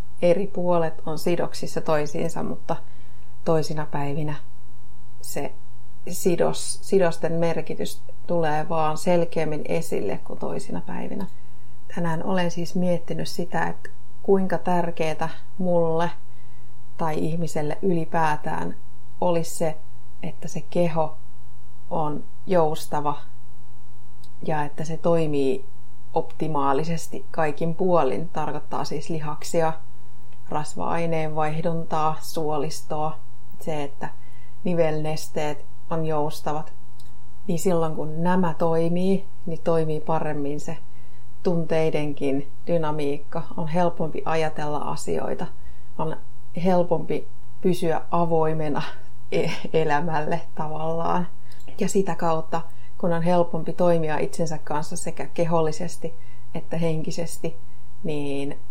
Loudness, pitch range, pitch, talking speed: -26 LUFS, 120-170 Hz, 155 Hz, 95 wpm